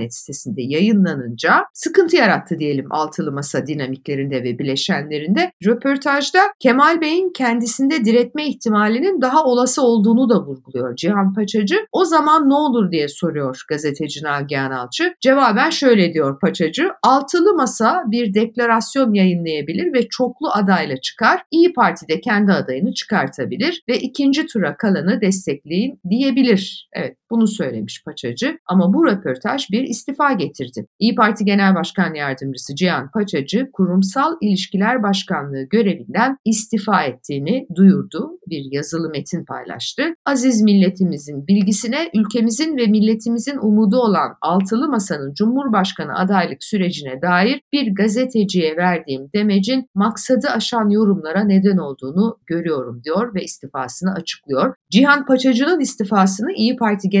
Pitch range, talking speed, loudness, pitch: 165-250 Hz, 125 wpm, -17 LUFS, 205 Hz